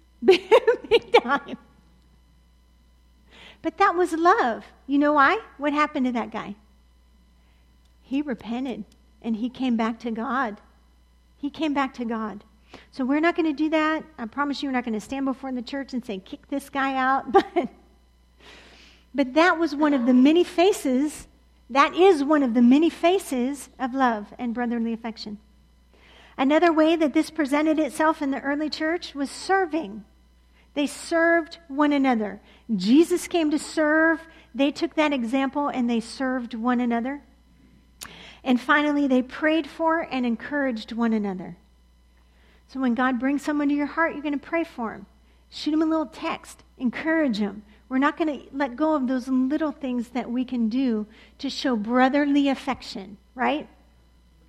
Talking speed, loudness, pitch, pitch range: 165 wpm, -23 LUFS, 265 Hz, 225-305 Hz